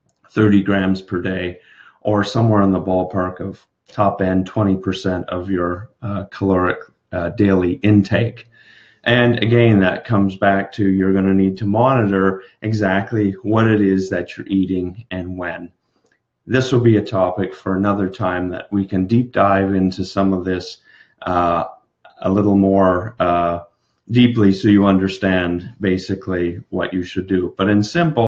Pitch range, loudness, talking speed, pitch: 90-105 Hz, -18 LUFS, 160 wpm, 95 Hz